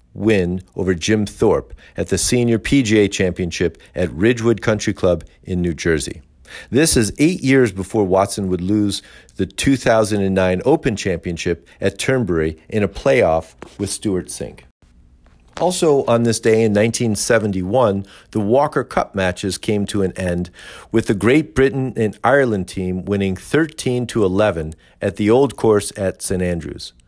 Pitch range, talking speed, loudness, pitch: 90-115 Hz, 150 wpm, -18 LUFS, 100 Hz